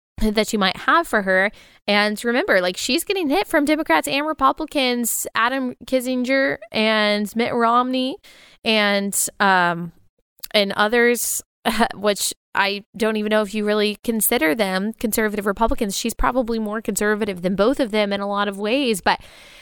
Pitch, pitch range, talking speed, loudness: 220 Hz, 210-255 Hz, 155 wpm, -20 LUFS